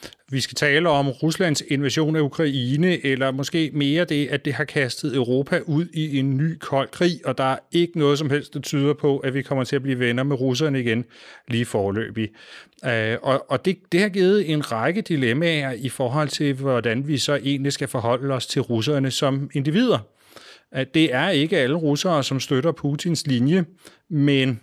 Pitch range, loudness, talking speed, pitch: 130-155 Hz, -22 LUFS, 185 wpm, 140 Hz